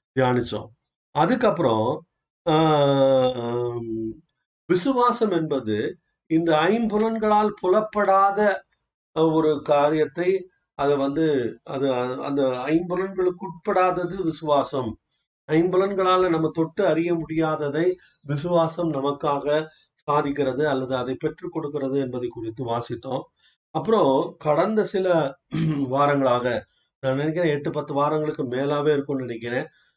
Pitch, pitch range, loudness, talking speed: 150 Hz, 135-175 Hz, -23 LUFS, 90 wpm